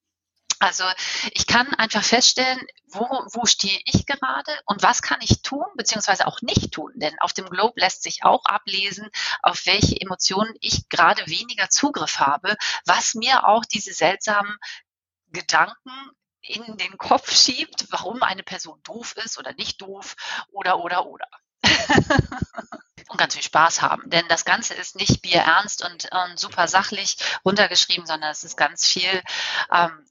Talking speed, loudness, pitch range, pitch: 155 wpm, -20 LUFS, 185-240 Hz, 205 Hz